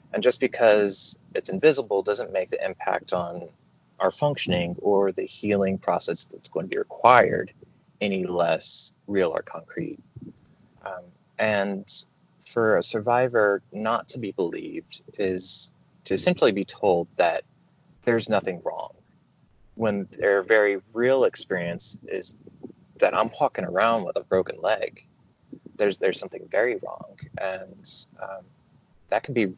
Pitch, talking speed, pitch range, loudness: 105 Hz, 140 wpm, 95-125 Hz, -24 LUFS